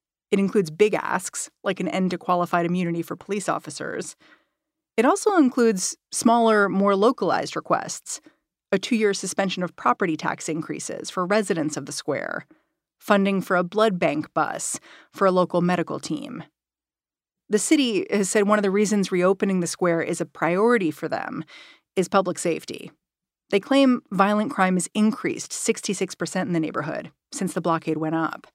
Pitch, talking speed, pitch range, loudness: 195 Hz, 165 wpm, 175-215 Hz, -23 LUFS